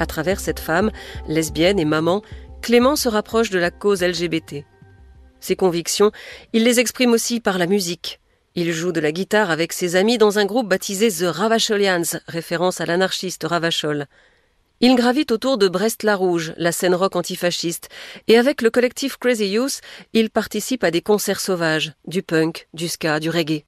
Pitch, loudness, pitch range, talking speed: 185 Hz, -19 LUFS, 170-220 Hz, 175 wpm